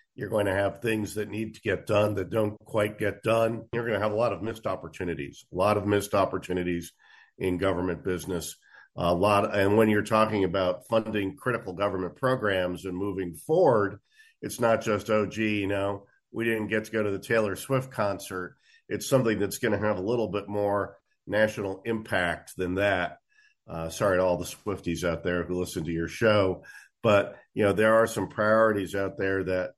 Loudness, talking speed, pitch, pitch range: -27 LUFS, 205 wpm, 100 Hz, 95-110 Hz